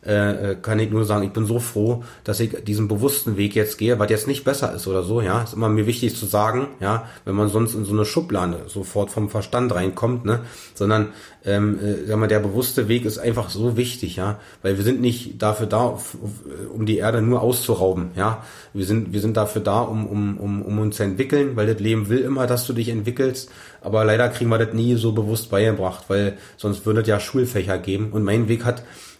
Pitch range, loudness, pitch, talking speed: 105-120 Hz, -21 LUFS, 110 Hz, 225 wpm